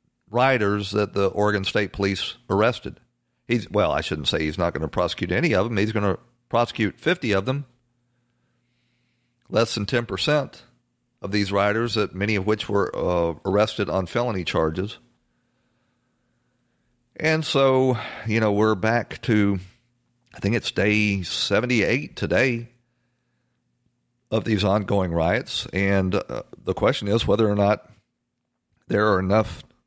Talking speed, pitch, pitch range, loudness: 145 wpm, 105 Hz, 100-120 Hz, -23 LUFS